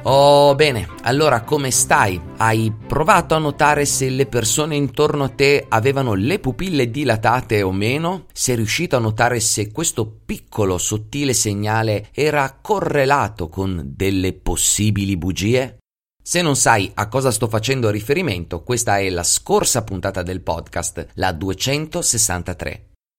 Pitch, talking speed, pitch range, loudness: 115 Hz, 135 wpm, 95-140 Hz, -18 LUFS